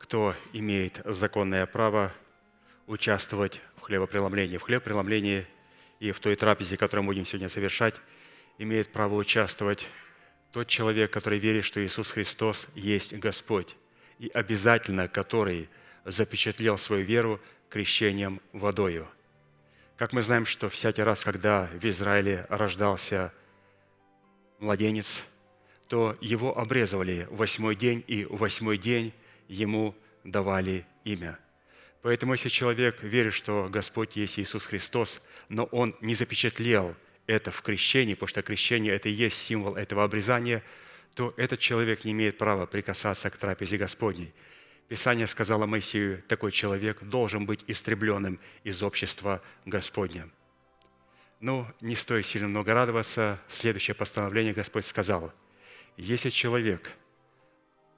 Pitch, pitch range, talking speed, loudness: 105 Hz, 100-110 Hz, 125 wpm, -28 LUFS